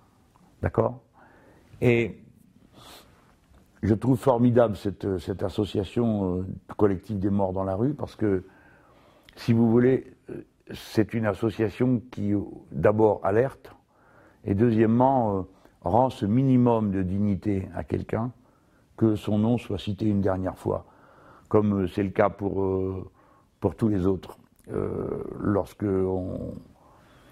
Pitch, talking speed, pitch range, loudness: 105 Hz, 125 wpm, 95-115 Hz, -26 LUFS